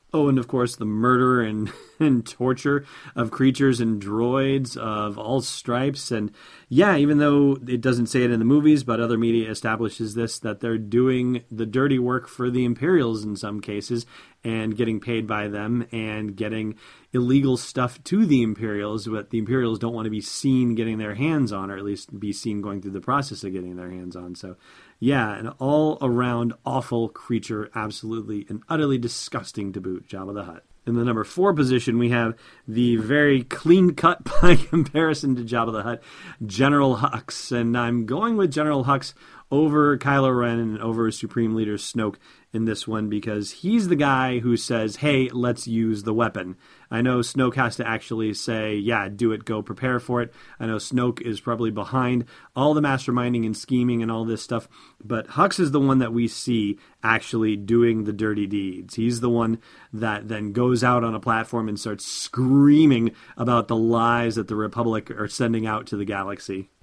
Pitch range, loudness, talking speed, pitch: 110-130 Hz, -23 LUFS, 190 wpm, 115 Hz